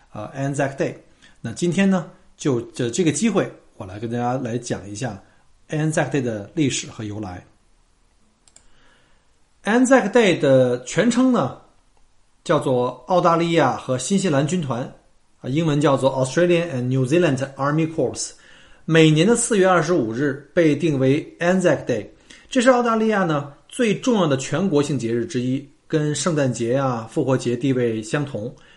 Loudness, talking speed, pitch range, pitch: -20 LUFS, 325 characters per minute, 125-175 Hz, 145 Hz